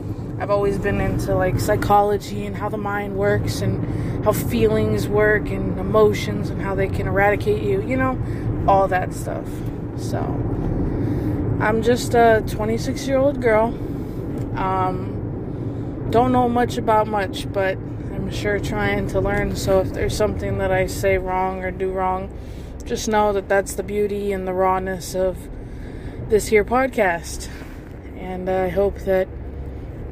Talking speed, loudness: 150 wpm, -21 LUFS